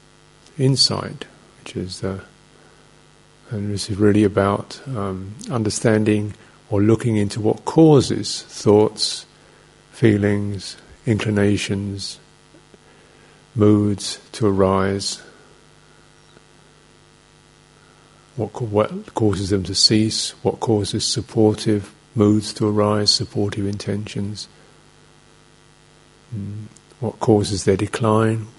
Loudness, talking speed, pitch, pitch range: -19 LUFS, 90 wpm, 105 Hz, 100-110 Hz